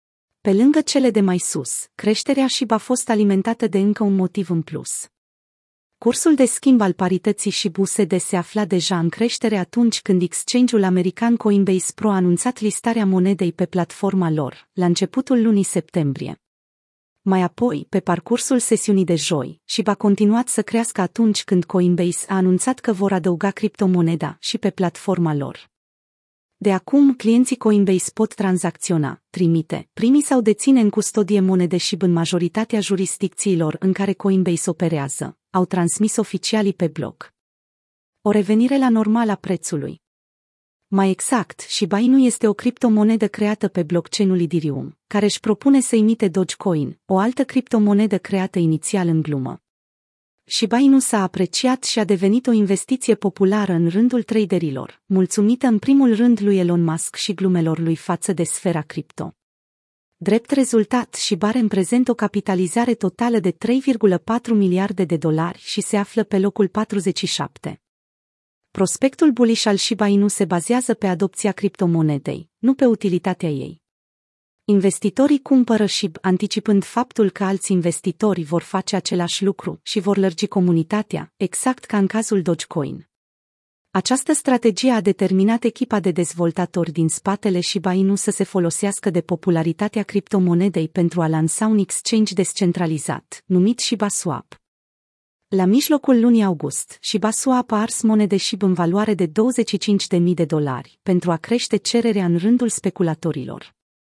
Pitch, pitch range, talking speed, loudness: 200 Hz, 180-220 Hz, 145 wpm, -19 LUFS